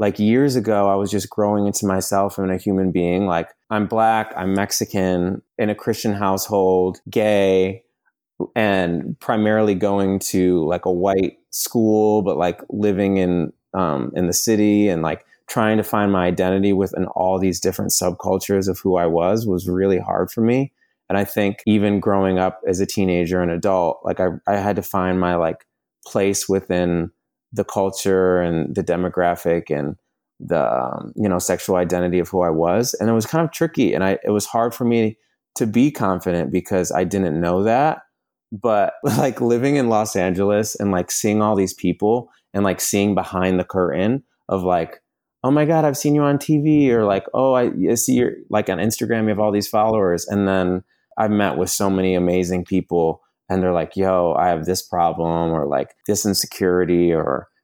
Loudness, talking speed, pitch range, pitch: -19 LUFS, 190 wpm, 90-105 Hz, 95 Hz